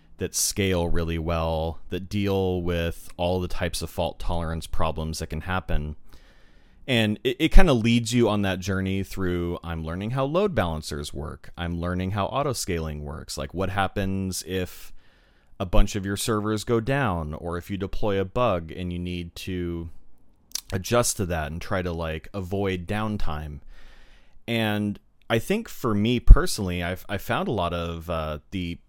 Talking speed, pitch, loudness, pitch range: 175 wpm, 90 Hz, -27 LUFS, 85-105 Hz